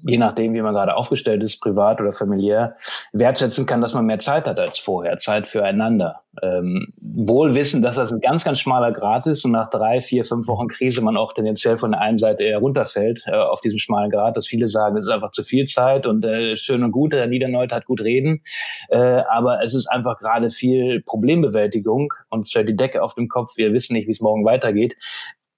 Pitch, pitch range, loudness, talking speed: 115 Hz, 110-125 Hz, -19 LUFS, 220 wpm